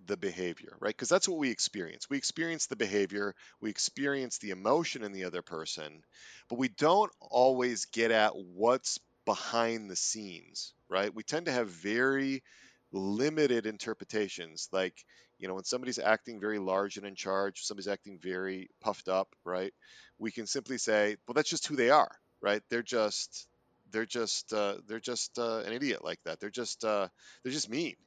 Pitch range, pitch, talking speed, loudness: 95-120 Hz, 105 Hz, 180 wpm, -33 LUFS